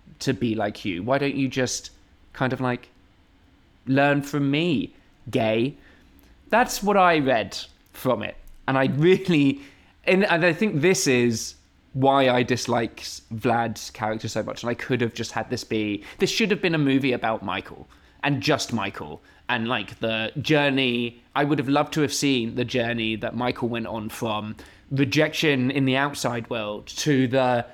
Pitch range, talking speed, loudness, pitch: 110-140 Hz, 175 wpm, -23 LUFS, 125 Hz